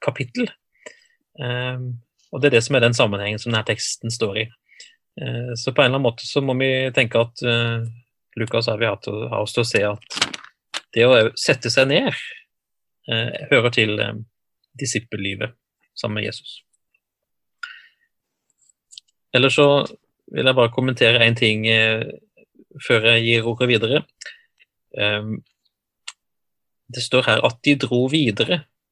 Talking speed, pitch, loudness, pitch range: 140 wpm, 120 Hz, -19 LUFS, 115-135 Hz